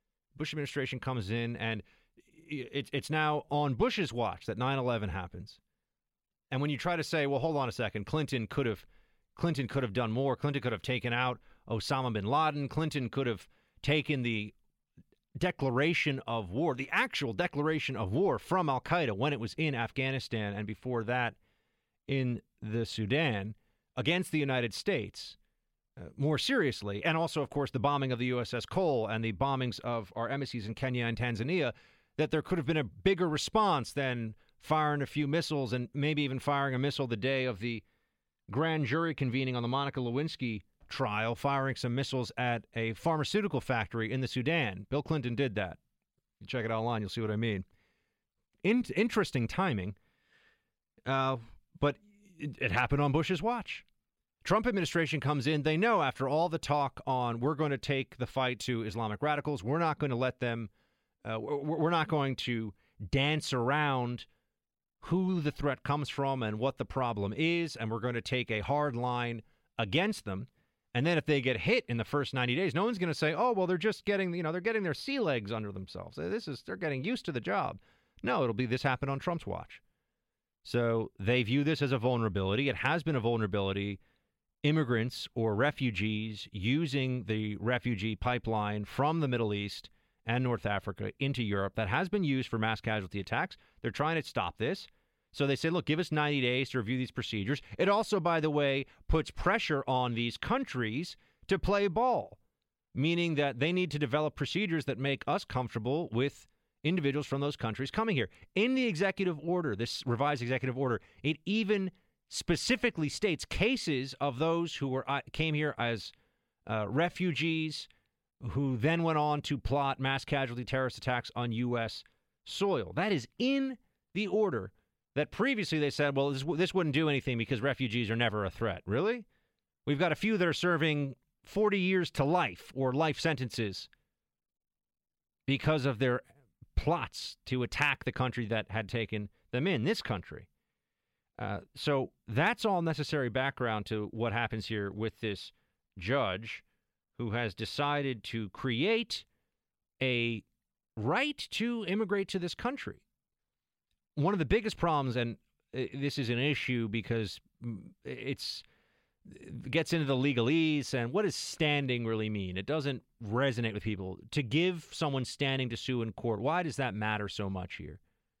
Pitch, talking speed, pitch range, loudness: 135 Hz, 175 wpm, 115-155 Hz, -32 LUFS